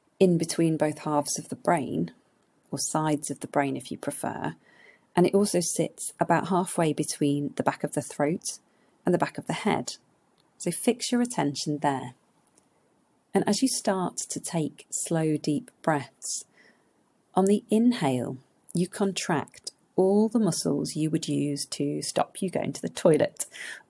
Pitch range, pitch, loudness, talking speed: 145-195 Hz, 165 Hz, -27 LUFS, 165 wpm